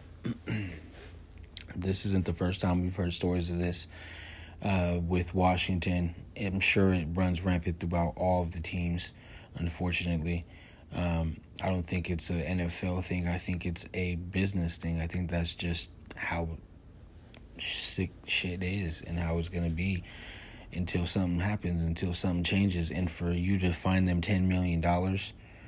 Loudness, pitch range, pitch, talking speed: -32 LUFS, 85-95 Hz, 90 Hz, 155 wpm